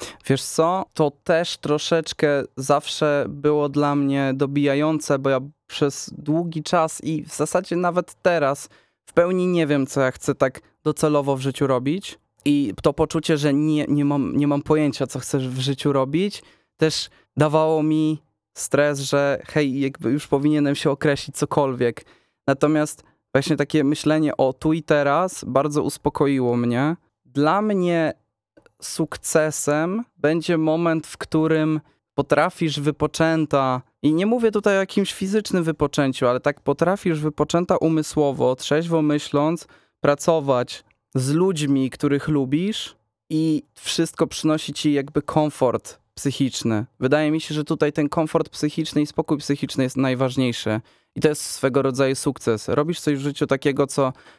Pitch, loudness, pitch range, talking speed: 150 Hz, -22 LUFS, 140-160 Hz, 145 wpm